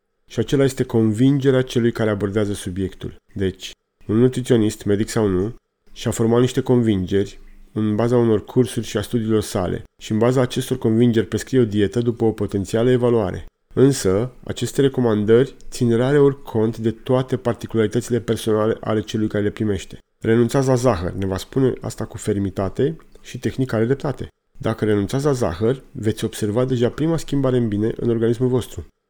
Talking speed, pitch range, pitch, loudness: 165 wpm, 105-125 Hz, 115 Hz, -20 LUFS